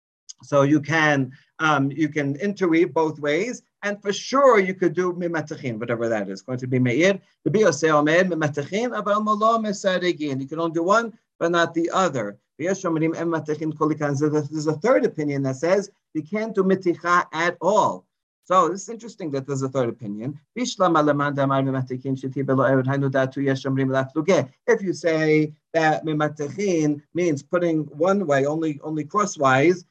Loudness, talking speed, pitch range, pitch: -22 LUFS, 125 wpm, 140-180 Hz, 155 Hz